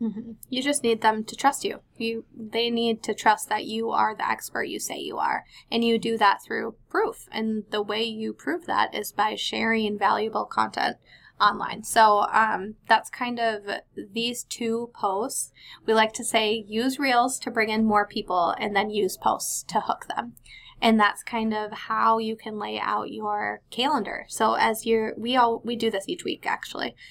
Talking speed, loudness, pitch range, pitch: 195 wpm, -25 LUFS, 215-235 Hz, 225 Hz